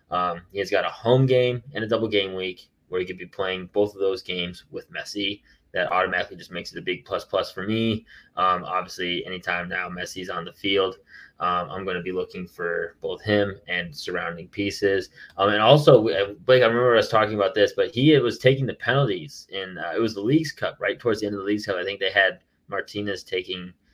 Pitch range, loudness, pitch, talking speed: 90-115 Hz, -24 LUFS, 100 Hz, 230 wpm